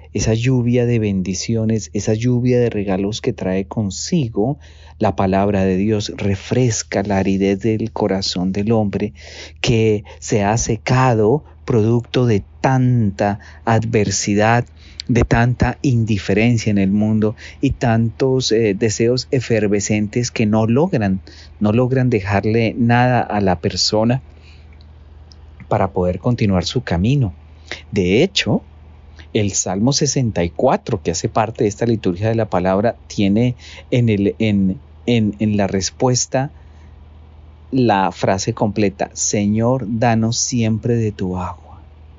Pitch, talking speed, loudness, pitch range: 105 Hz, 125 wpm, -17 LUFS, 95-115 Hz